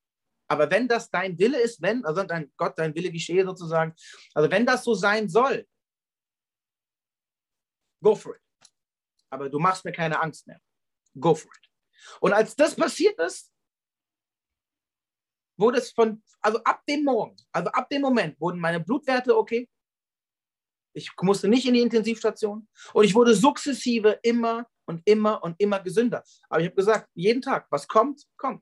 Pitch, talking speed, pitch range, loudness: 215 Hz, 165 wpm, 170-235 Hz, -24 LUFS